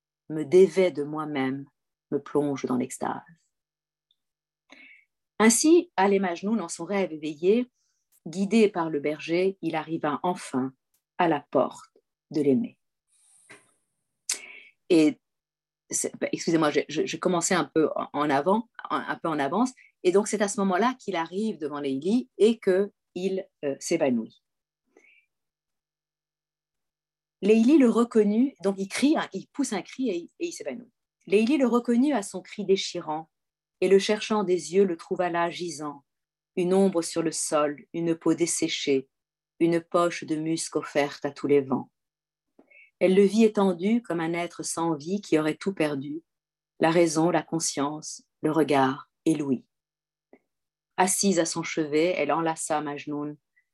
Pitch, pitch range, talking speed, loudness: 170 Hz, 155-200 Hz, 145 wpm, -26 LUFS